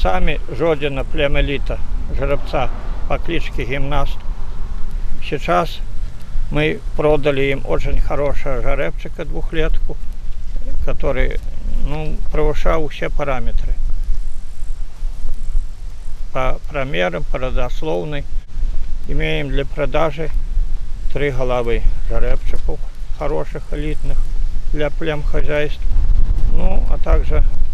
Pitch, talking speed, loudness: 130 Hz, 80 wpm, -22 LUFS